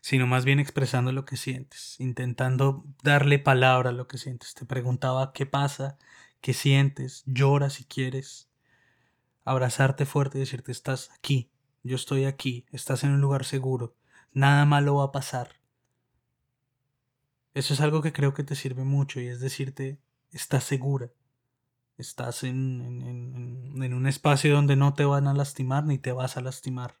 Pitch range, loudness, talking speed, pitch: 125-140 Hz, -26 LUFS, 165 wpm, 135 Hz